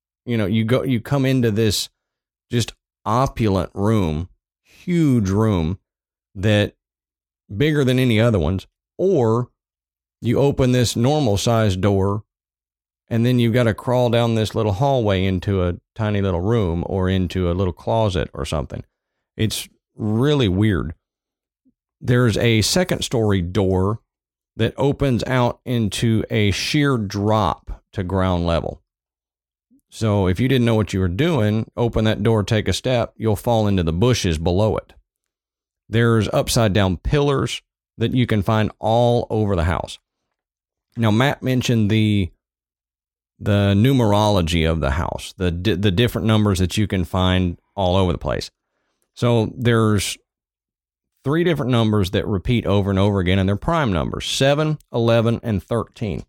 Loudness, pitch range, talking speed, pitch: -19 LUFS, 95-120 Hz, 150 wpm, 105 Hz